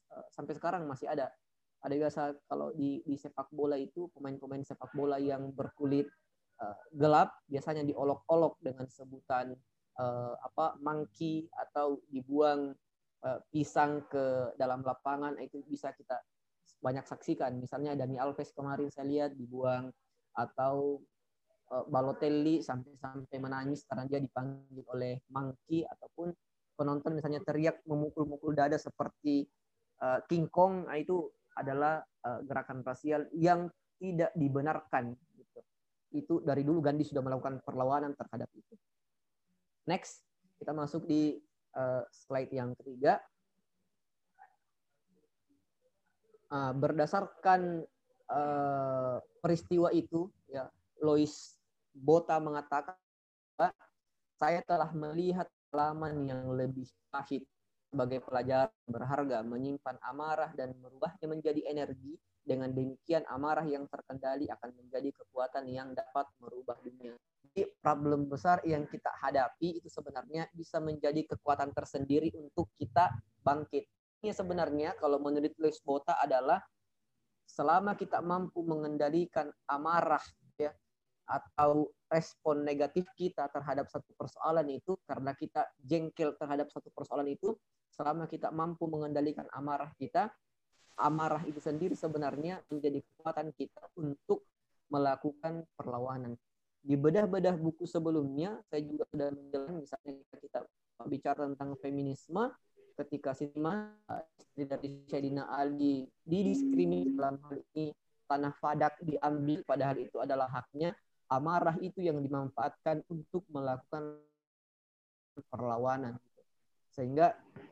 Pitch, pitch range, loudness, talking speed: 145 Hz, 135-160 Hz, -35 LUFS, 110 wpm